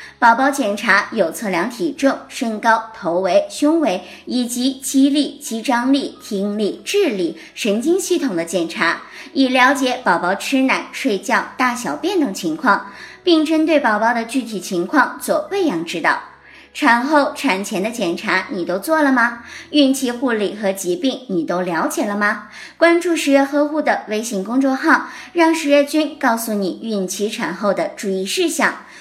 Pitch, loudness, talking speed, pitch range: 260 Hz, -18 LUFS, 240 characters per minute, 210-305 Hz